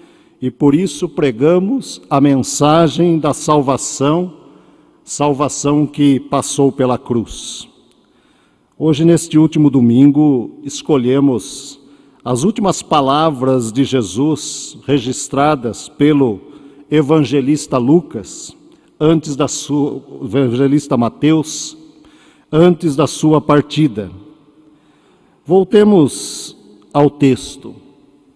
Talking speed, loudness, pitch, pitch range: 85 wpm, -14 LUFS, 145 Hz, 135-155 Hz